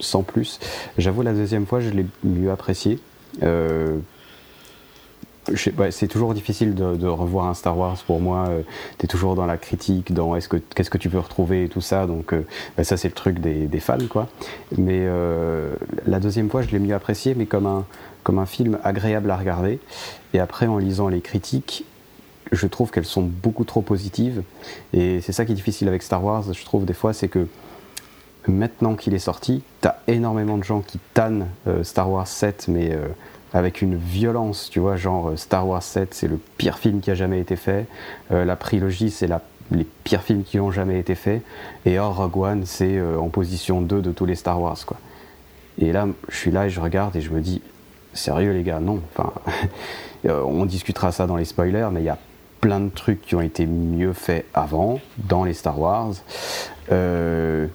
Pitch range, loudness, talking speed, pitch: 90-105 Hz, -23 LUFS, 210 wpm, 95 Hz